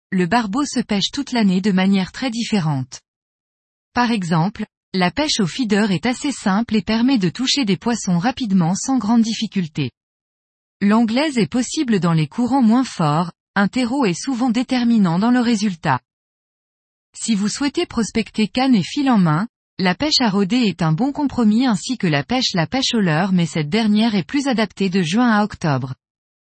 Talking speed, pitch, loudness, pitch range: 180 wpm, 215 Hz, -18 LUFS, 180-245 Hz